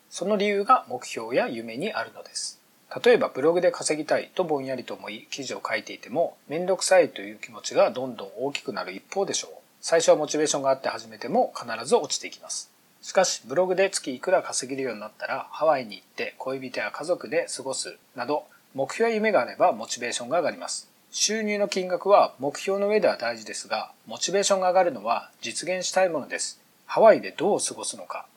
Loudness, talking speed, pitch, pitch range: -25 LUFS, 440 characters per minute, 185 Hz, 150-200 Hz